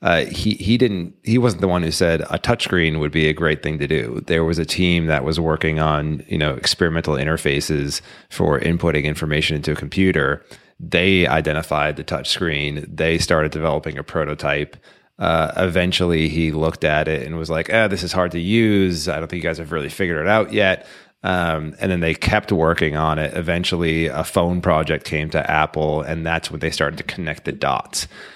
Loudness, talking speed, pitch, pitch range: -19 LUFS, 205 wpm, 80 Hz, 75-90 Hz